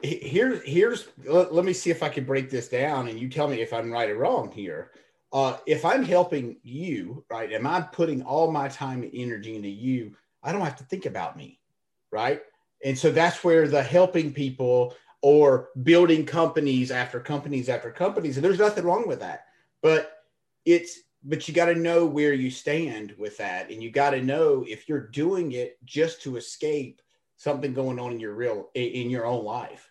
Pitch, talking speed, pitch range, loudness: 145 Hz, 205 wpm, 125-165 Hz, -25 LUFS